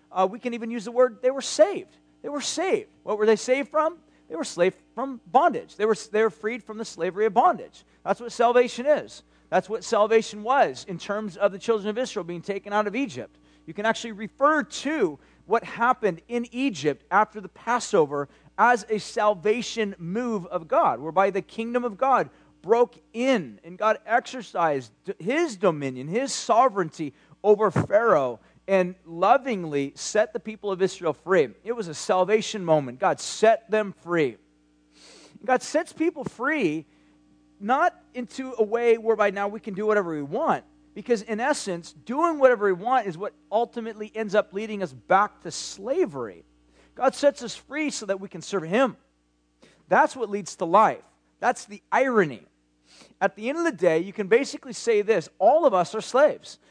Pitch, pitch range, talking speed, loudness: 215 Hz, 185-245 Hz, 180 wpm, -24 LUFS